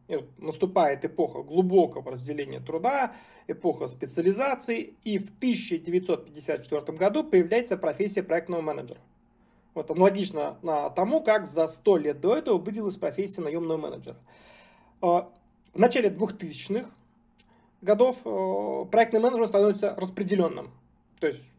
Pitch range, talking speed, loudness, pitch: 165-220 Hz, 105 wpm, -27 LUFS, 195 Hz